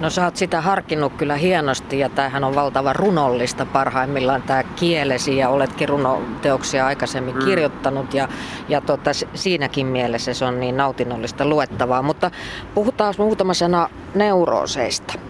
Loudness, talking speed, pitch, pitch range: -20 LUFS, 135 wpm, 140 Hz, 130-170 Hz